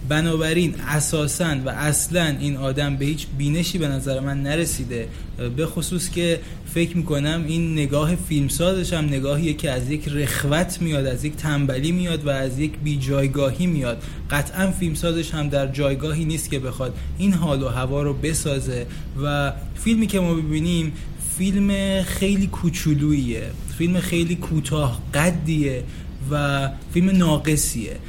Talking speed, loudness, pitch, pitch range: 145 wpm, -22 LUFS, 150 Hz, 140-170 Hz